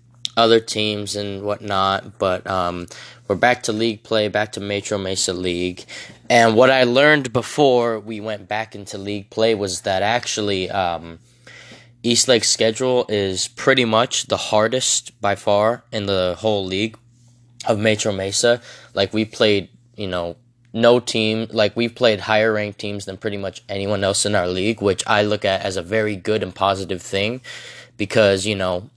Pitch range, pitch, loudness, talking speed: 100-120 Hz, 110 Hz, -19 LUFS, 170 wpm